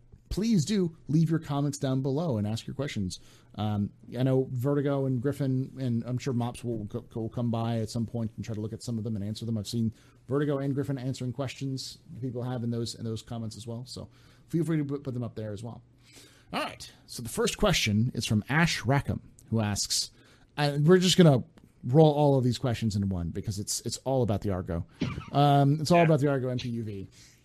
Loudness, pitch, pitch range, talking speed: -28 LUFS, 125 Hz, 110-140 Hz, 225 wpm